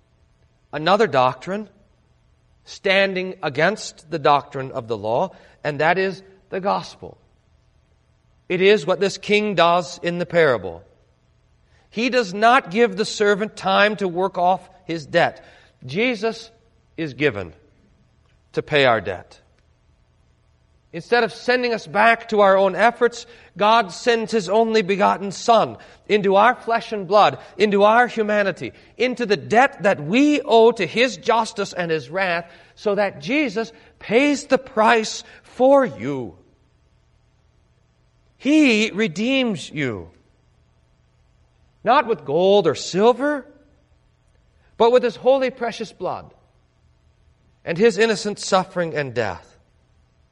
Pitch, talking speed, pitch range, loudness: 205 Hz, 125 wpm, 180-230 Hz, -19 LUFS